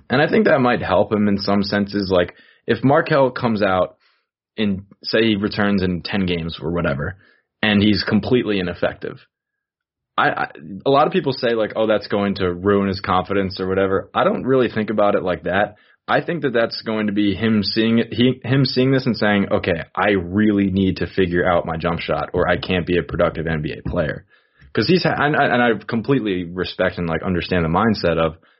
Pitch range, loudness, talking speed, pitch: 90-110 Hz, -19 LUFS, 210 wpm, 100 Hz